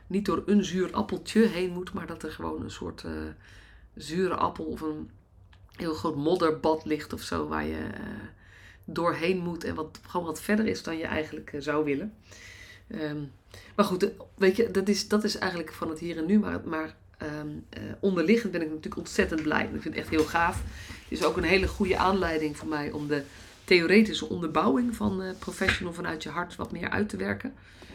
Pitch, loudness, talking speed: 160 Hz, -28 LUFS, 210 wpm